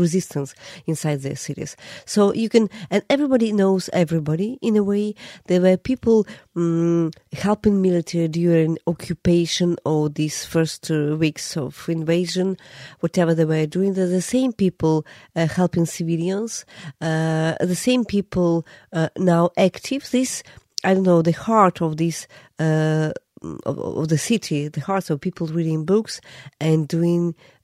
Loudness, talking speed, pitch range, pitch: -21 LUFS, 150 wpm, 160-190 Hz, 170 Hz